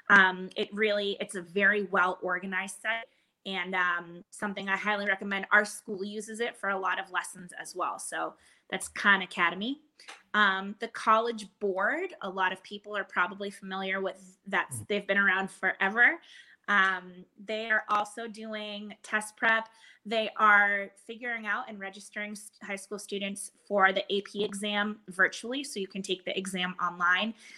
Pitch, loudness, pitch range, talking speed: 200 Hz, -29 LUFS, 190-215 Hz, 165 wpm